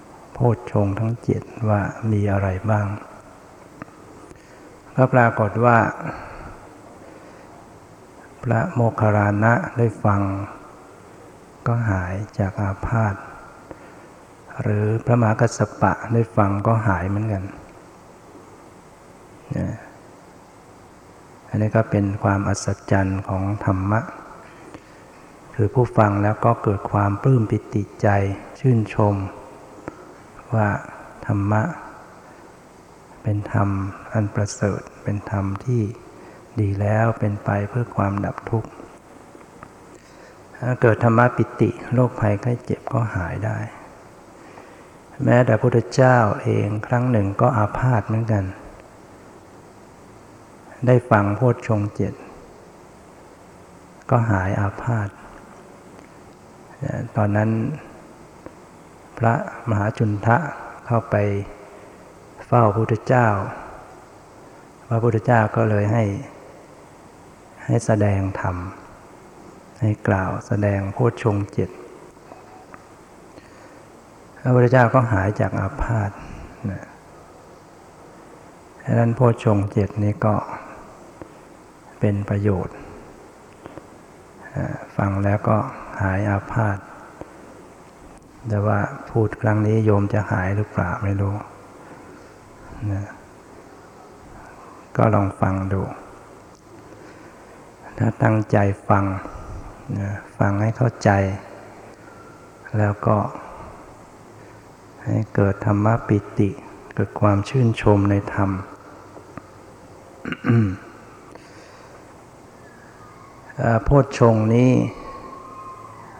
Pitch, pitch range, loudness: 105 Hz, 100-115 Hz, -21 LUFS